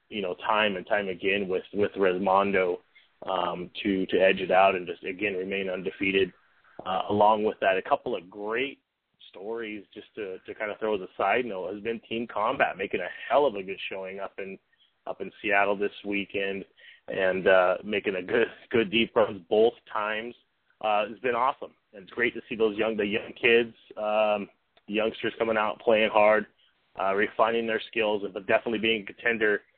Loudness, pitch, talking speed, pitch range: -27 LUFS, 105 Hz, 190 wpm, 95-110 Hz